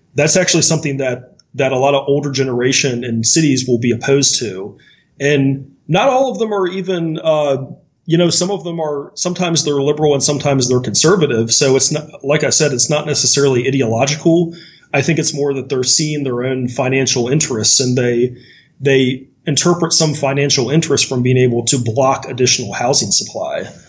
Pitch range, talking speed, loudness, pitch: 130-155 Hz, 185 wpm, -14 LUFS, 140 Hz